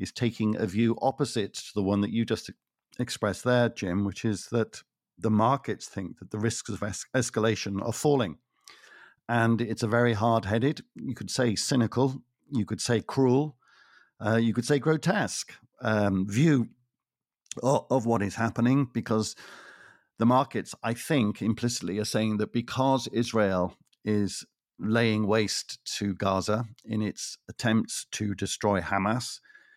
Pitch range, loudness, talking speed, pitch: 105-125 Hz, -28 LUFS, 155 wpm, 115 Hz